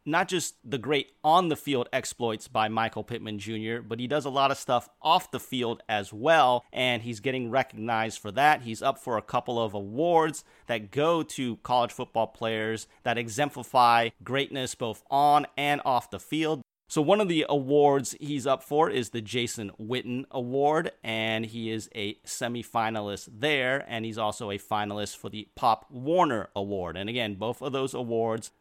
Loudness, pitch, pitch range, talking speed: -28 LUFS, 120 Hz, 110-140 Hz, 180 wpm